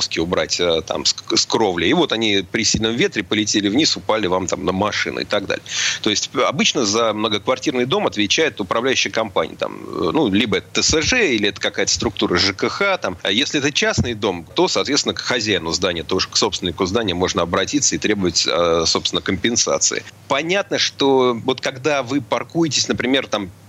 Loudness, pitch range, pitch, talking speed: -18 LUFS, 95-125 Hz, 110 Hz, 170 wpm